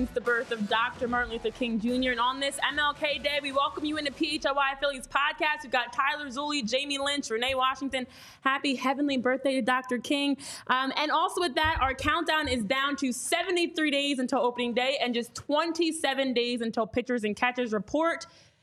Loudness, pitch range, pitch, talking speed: -28 LUFS, 250-295 Hz, 270 Hz, 190 wpm